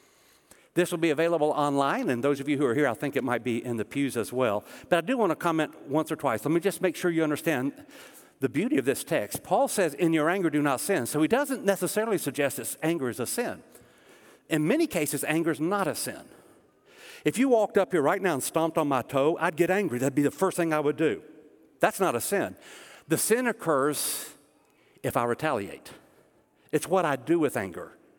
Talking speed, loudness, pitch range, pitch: 230 wpm, -27 LUFS, 140-180 Hz, 155 Hz